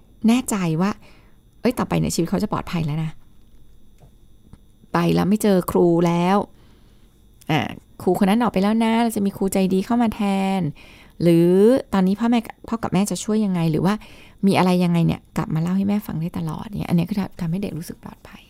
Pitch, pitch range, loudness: 190 Hz, 170-205 Hz, -21 LUFS